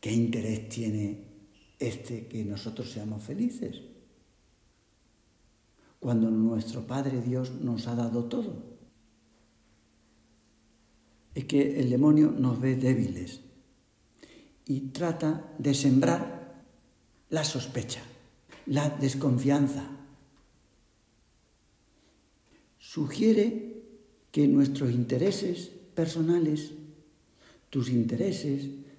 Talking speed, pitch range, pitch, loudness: 80 wpm, 115-150 Hz, 130 Hz, -29 LUFS